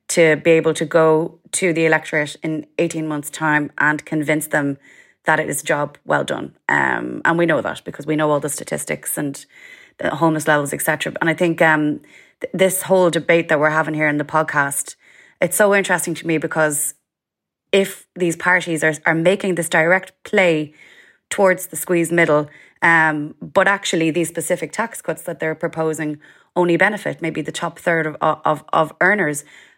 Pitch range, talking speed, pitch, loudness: 155-180 Hz, 185 wpm, 160 Hz, -18 LUFS